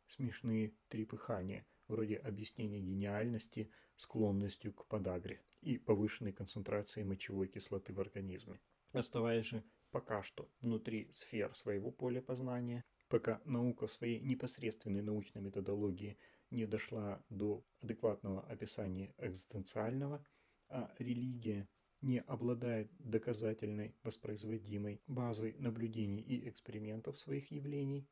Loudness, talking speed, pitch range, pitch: -43 LUFS, 105 wpm, 105-120 Hz, 110 Hz